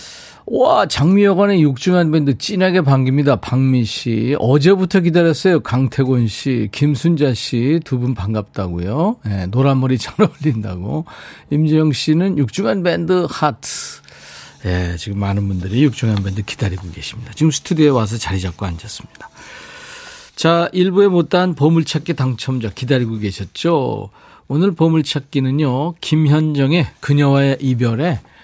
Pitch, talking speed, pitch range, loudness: 140 Hz, 310 characters per minute, 115-165 Hz, -16 LUFS